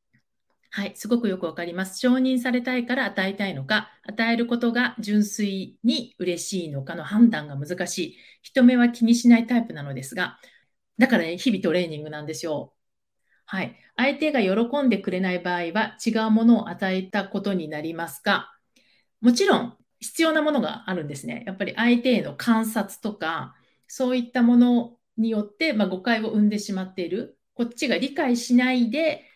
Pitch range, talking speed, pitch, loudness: 185-240 Hz, 355 characters per minute, 220 Hz, -23 LUFS